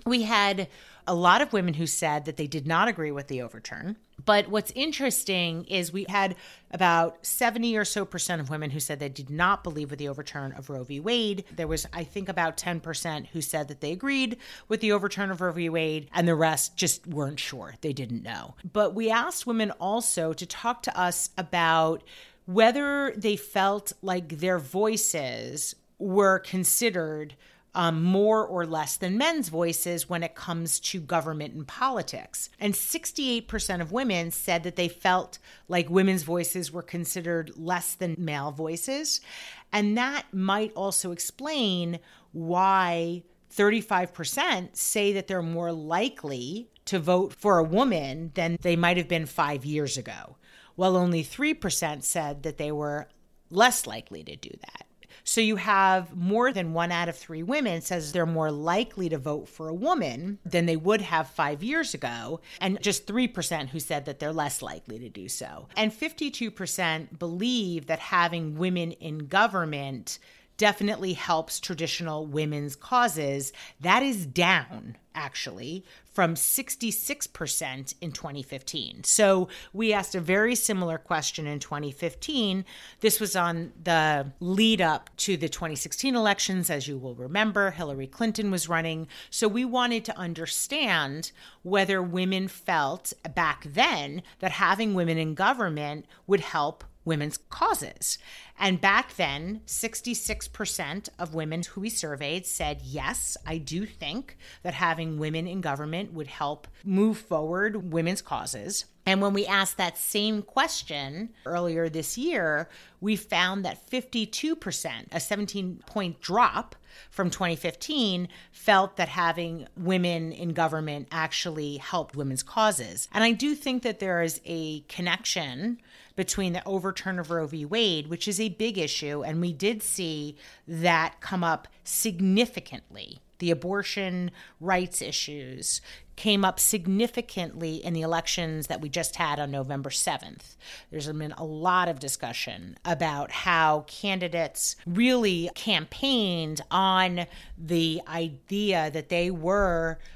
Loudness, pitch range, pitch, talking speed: -27 LUFS, 160-205 Hz, 175 Hz, 150 wpm